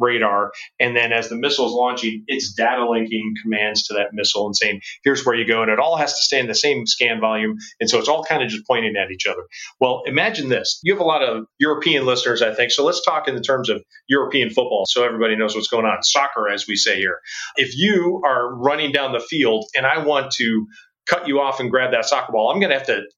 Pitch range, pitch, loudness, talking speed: 110-140 Hz, 120 Hz, -19 LUFS, 255 wpm